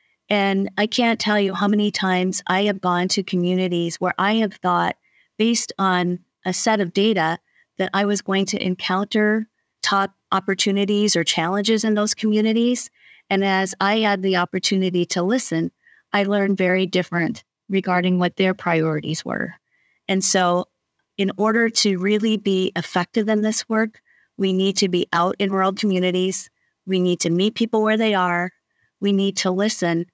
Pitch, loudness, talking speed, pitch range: 195 Hz, -20 LUFS, 165 wpm, 180-210 Hz